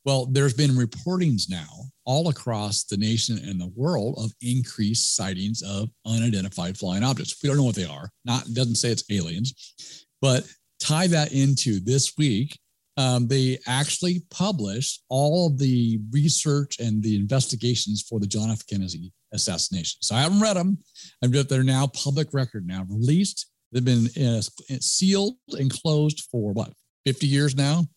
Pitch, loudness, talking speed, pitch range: 130 Hz, -24 LUFS, 165 wpm, 110-145 Hz